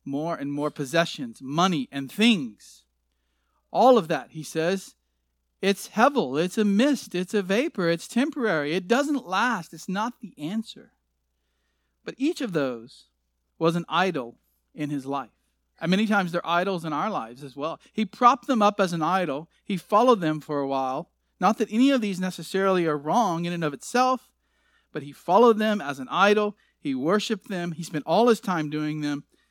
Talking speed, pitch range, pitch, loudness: 185 wpm, 145-215 Hz, 175 Hz, -25 LUFS